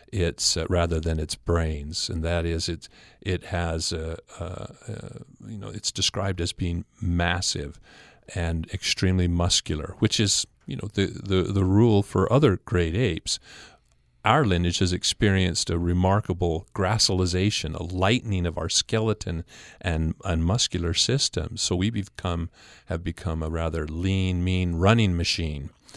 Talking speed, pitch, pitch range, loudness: 150 wpm, 90 Hz, 85-100 Hz, -25 LUFS